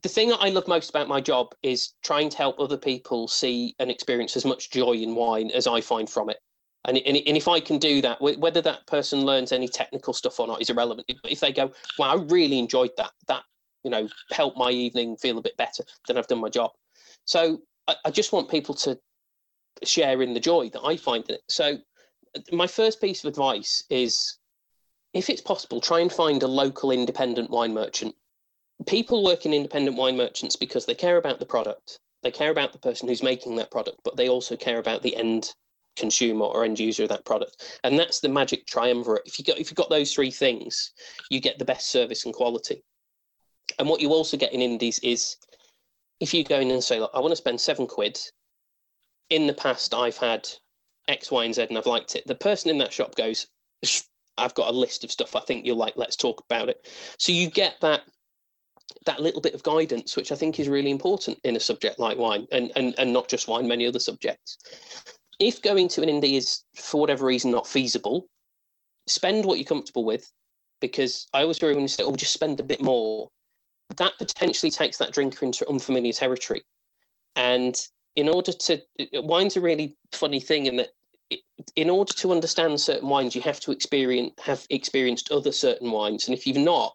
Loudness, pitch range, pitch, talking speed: -25 LUFS, 125-195 Hz, 145 Hz, 215 wpm